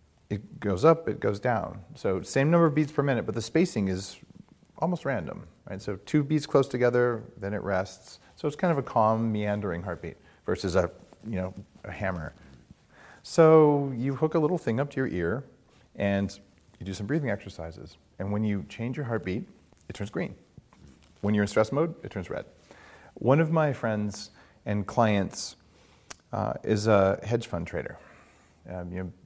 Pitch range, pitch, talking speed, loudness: 95-135 Hz, 105 Hz, 185 wpm, -28 LUFS